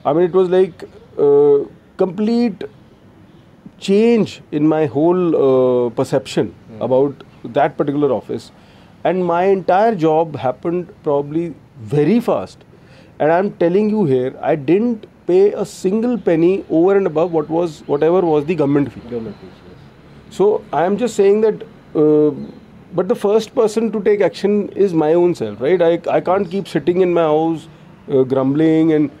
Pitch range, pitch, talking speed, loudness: 150-205 Hz, 175 Hz, 160 wpm, -16 LUFS